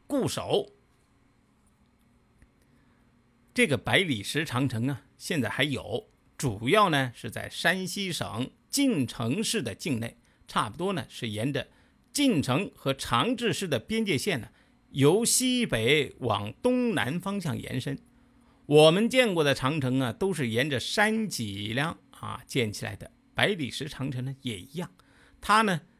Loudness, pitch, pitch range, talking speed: -27 LUFS, 140 Hz, 125-195 Hz, 200 characters per minute